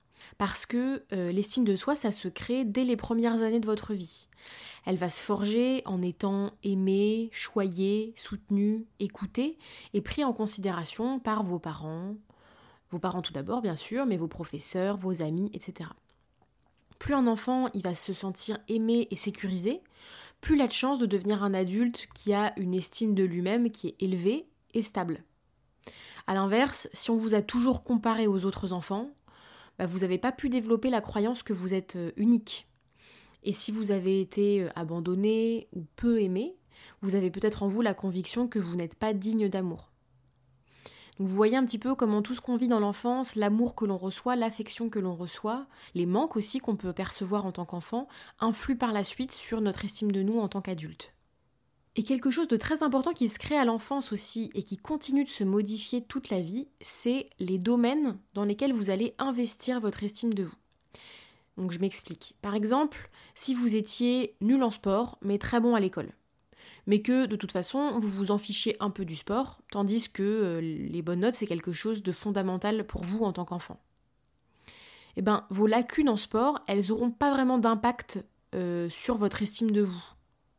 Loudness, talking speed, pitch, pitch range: -29 LUFS, 190 wpm, 210 Hz, 190-235 Hz